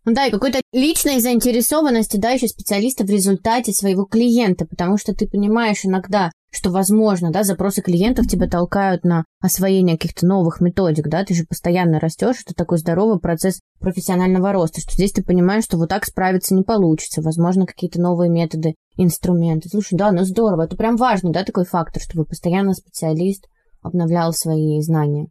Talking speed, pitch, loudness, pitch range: 170 wpm, 185 Hz, -18 LUFS, 170-210 Hz